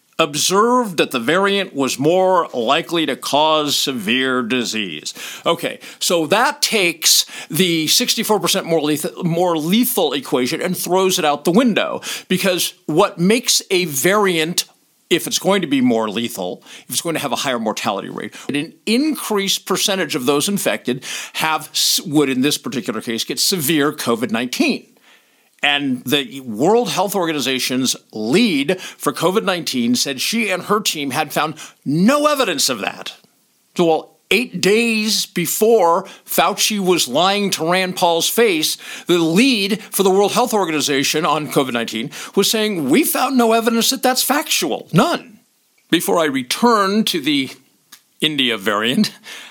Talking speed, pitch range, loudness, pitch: 150 wpm, 155-225 Hz, -17 LUFS, 185 Hz